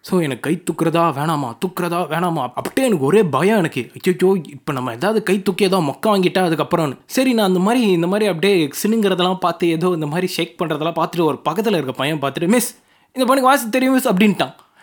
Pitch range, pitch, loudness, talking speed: 160-210 Hz, 180 Hz, -18 LUFS, 200 wpm